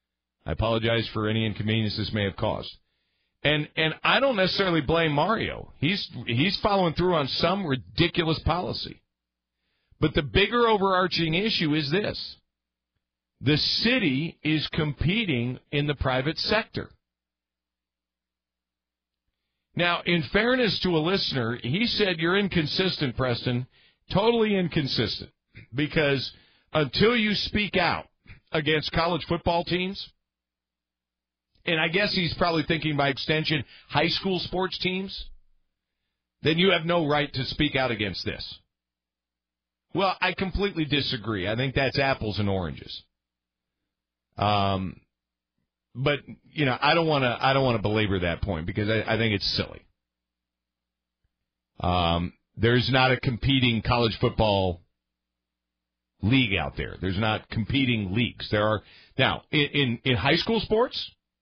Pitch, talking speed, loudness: 125 Hz, 135 wpm, -25 LUFS